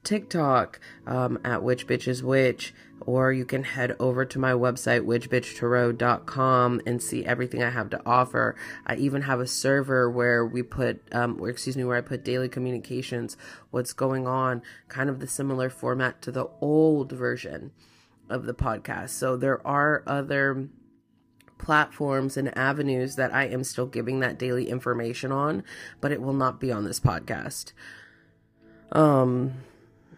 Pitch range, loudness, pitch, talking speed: 120-135 Hz, -26 LUFS, 125 Hz, 160 wpm